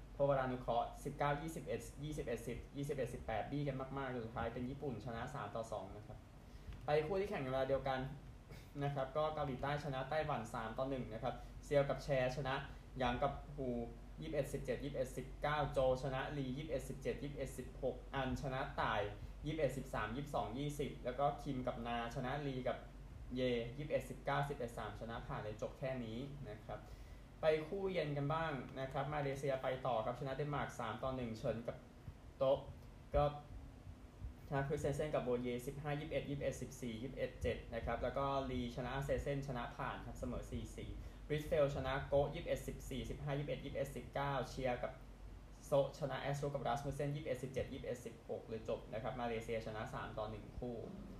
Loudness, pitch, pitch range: -42 LUFS, 130 Hz, 120-140 Hz